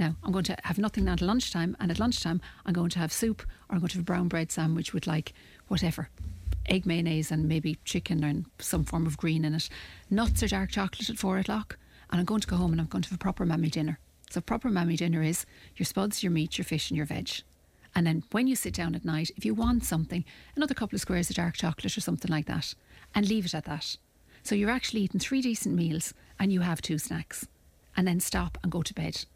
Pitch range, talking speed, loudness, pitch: 160-195 Hz, 255 wpm, -30 LUFS, 175 Hz